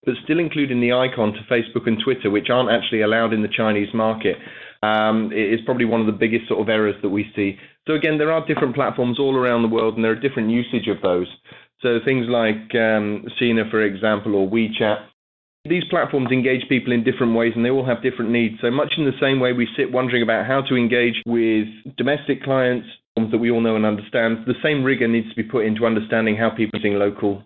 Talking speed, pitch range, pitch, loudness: 225 wpm, 110-125 Hz, 115 Hz, -20 LUFS